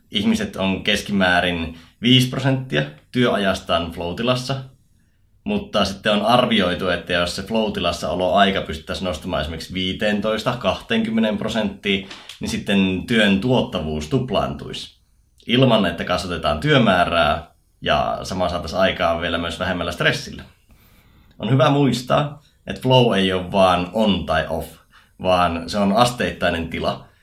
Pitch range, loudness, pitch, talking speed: 85-125 Hz, -20 LUFS, 95 Hz, 120 wpm